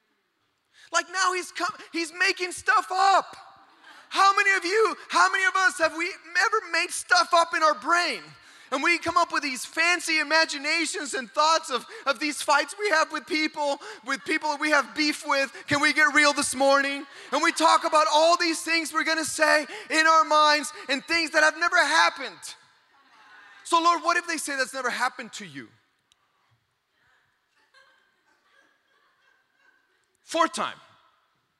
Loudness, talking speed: -23 LUFS, 165 wpm